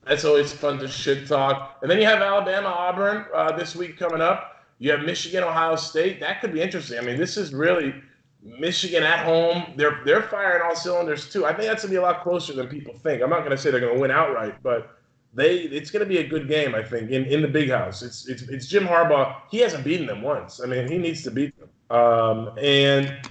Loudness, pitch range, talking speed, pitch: -22 LUFS, 135-180 Hz, 240 wpm, 155 Hz